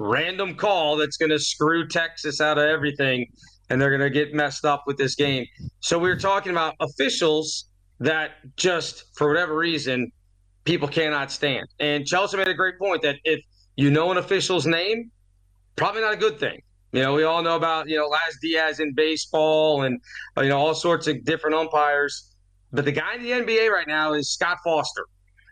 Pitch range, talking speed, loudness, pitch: 140-165 Hz, 195 wpm, -23 LUFS, 150 Hz